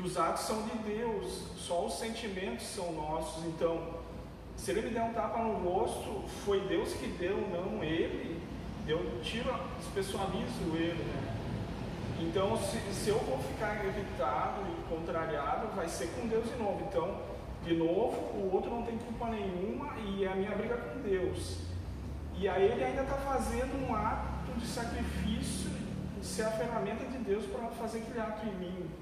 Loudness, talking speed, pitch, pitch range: -36 LUFS, 170 wpm, 200 Hz, 165-225 Hz